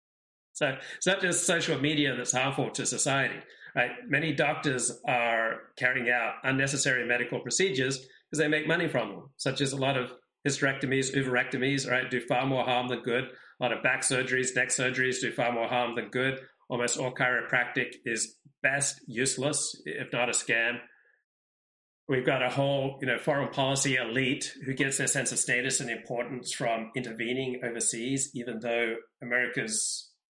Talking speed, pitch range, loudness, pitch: 170 wpm, 125-140 Hz, -28 LUFS, 130 Hz